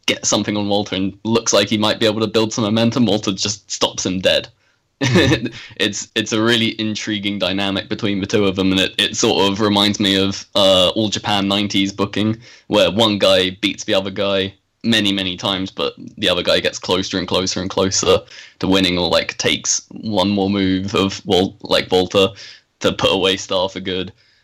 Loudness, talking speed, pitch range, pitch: -17 LUFS, 200 wpm, 95-110 Hz, 100 Hz